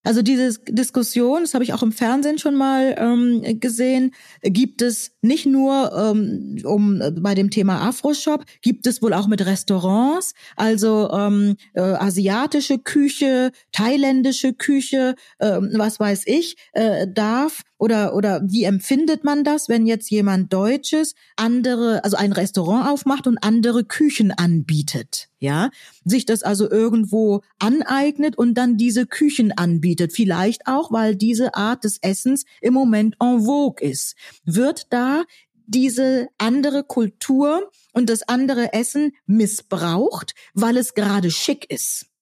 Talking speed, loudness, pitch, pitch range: 140 wpm, -19 LUFS, 230 Hz, 205-265 Hz